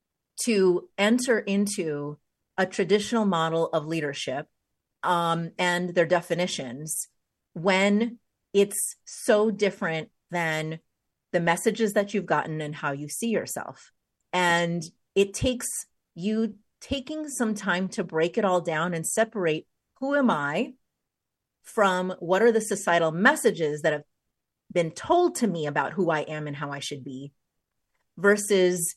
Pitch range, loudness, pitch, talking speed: 160-210 Hz, -26 LUFS, 180 Hz, 135 wpm